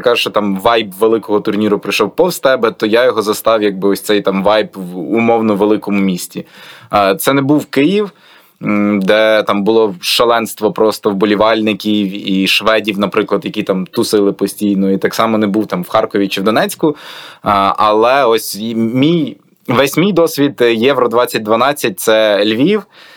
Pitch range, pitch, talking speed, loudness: 100-115 Hz, 105 Hz, 155 wpm, -13 LUFS